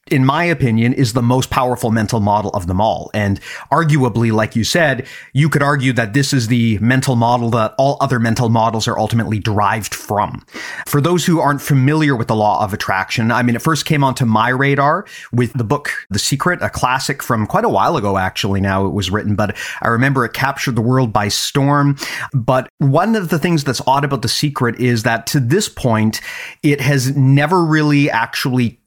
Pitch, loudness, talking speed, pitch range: 125 Hz, -15 LUFS, 205 wpm, 115-140 Hz